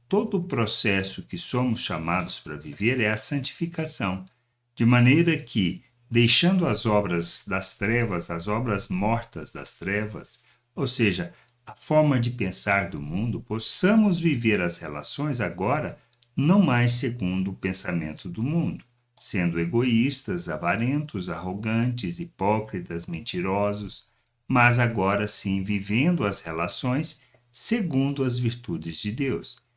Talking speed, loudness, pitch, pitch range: 125 wpm, -25 LUFS, 115 Hz, 95-130 Hz